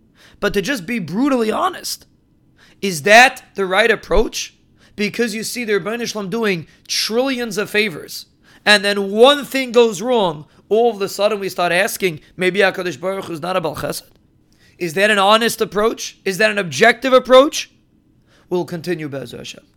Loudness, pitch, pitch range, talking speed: -16 LUFS, 210 Hz, 185-230 Hz, 165 wpm